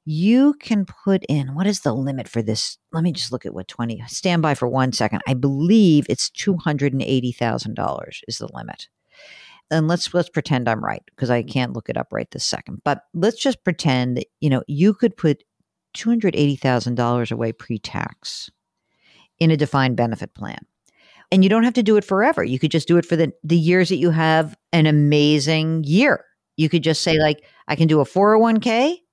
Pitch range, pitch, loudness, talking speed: 130-185 Hz, 155 Hz, -19 LUFS, 195 wpm